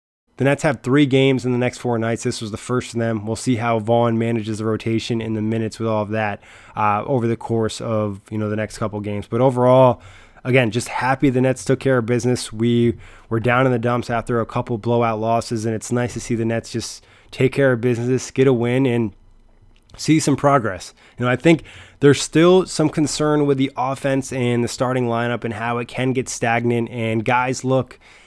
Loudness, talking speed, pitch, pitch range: -19 LUFS, 225 wpm, 120 Hz, 110-130 Hz